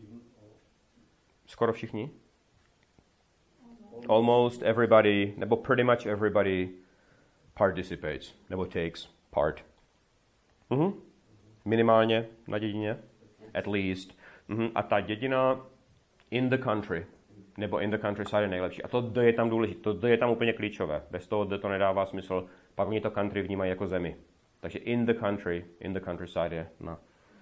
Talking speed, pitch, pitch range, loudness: 140 wpm, 105 Hz, 95-115 Hz, -29 LUFS